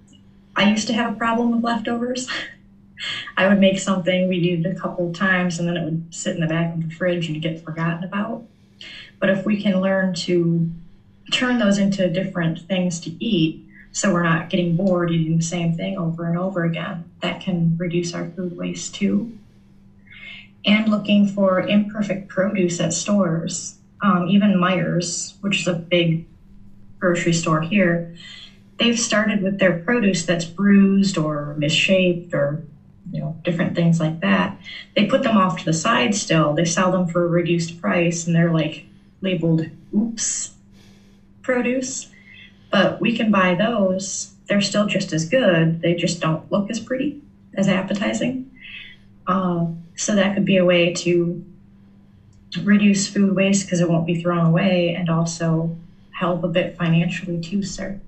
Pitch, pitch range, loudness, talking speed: 180 Hz, 165-195 Hz, -20 LUFS, 170 wpm